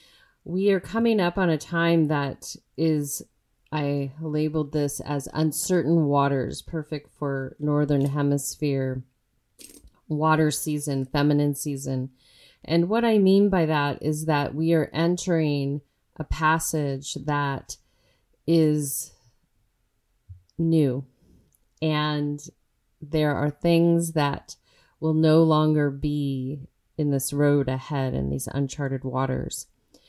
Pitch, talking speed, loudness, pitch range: 145 Hz, 110 wpm, -24 LUFS, 135-160 Hz